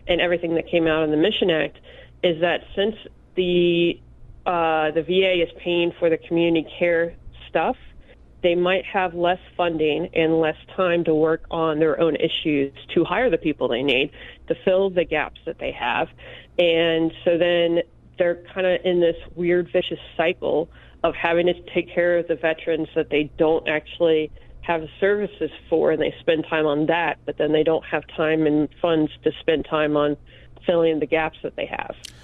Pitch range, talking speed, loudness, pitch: 155-175 Hz, 185 wpm, -22 LUFS, 165 Hz